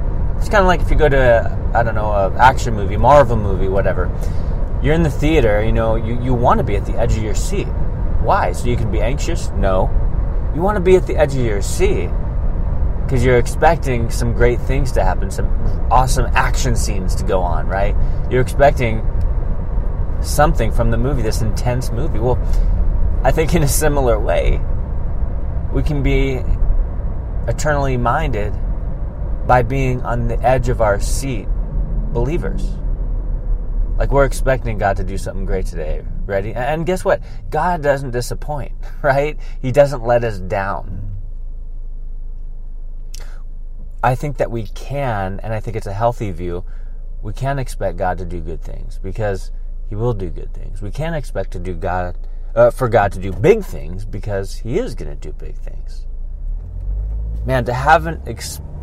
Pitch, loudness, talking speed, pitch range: 105 Hz, -18 LUFS, 175 wpm, 90-125 Hz